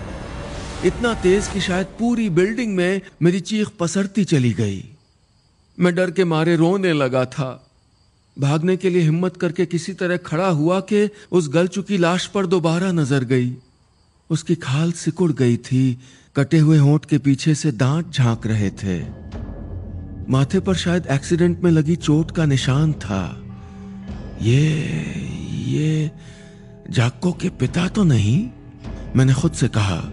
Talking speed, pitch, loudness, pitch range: 145 wpm, 155 Hz, -19 LUFS, 130-180 Hz